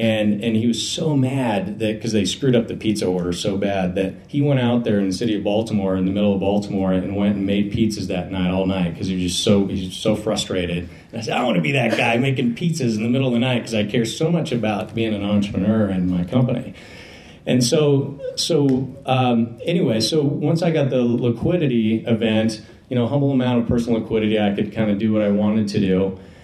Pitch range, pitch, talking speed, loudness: 100-125 Hz, 110 Hz, 245 wpm, -20 LUFS